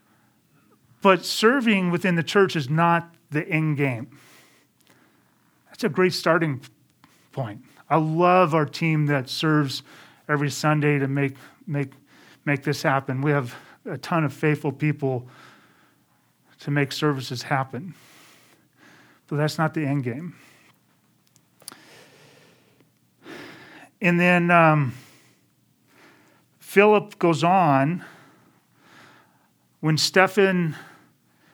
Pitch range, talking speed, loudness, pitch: 140-170 Hz, 105 wpm, -22 LUFS, 155 Hz